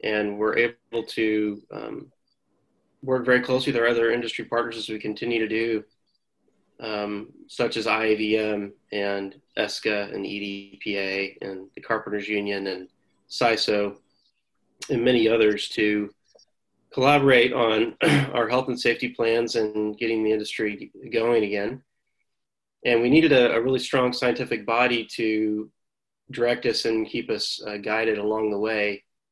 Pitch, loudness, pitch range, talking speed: 110 Hz, -24 LUFS, 105-120 Hz, 140 wpm